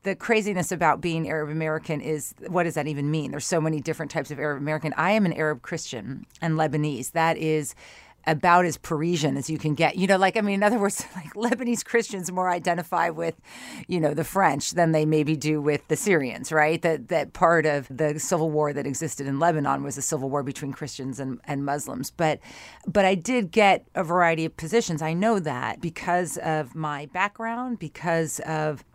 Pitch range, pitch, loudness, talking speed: 150-180 Hz, 160 Hz, -25 LUFS, 205 wpm